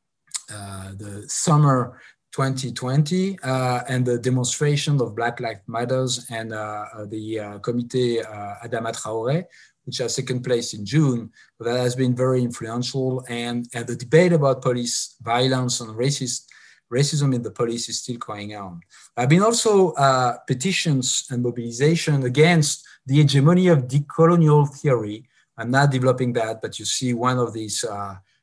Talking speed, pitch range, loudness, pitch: 150 wpm, 115-140 Hz, -21 LUFS, 125 Hz